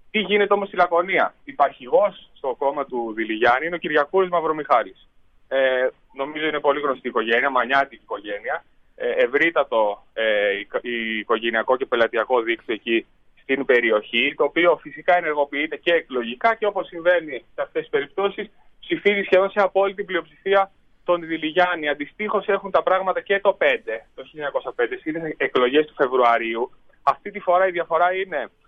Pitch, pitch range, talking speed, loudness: 170 Hz, 130-195 Hz, 155 wpm, -21 LUFS